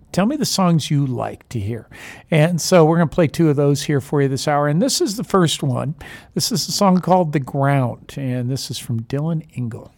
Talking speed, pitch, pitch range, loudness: 245 wpm, 145 Hz, 130-170 Hz, -18 LUFS